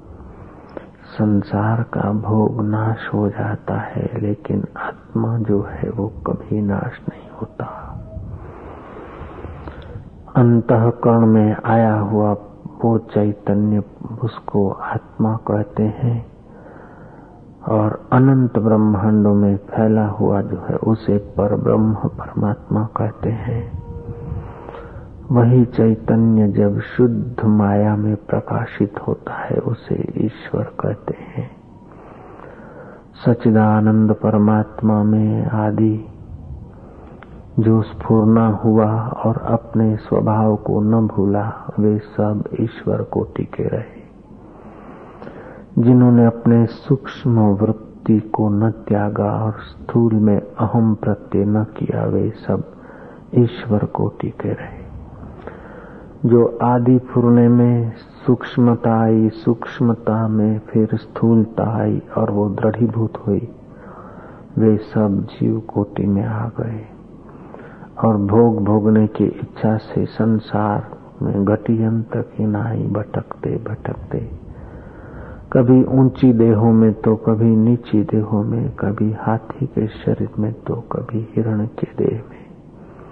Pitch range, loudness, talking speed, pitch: 105-115 Hz, -18 LUFS, 105 wpm, 110 Hz